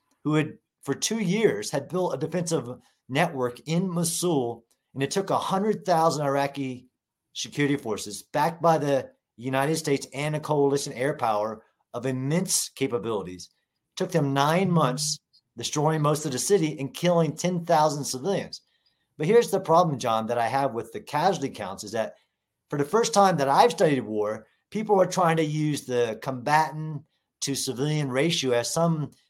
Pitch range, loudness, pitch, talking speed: 130-170 Hz, -25 LUFS, 145 Hz, 165 wpm